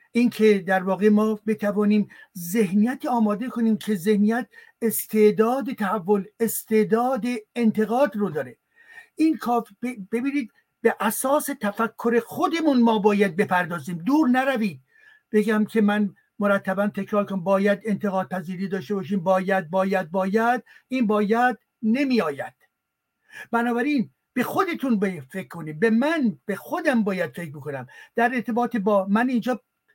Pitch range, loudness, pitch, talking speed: 200-245 Hz, -23 LUFS, 220 Hz, 125 wpm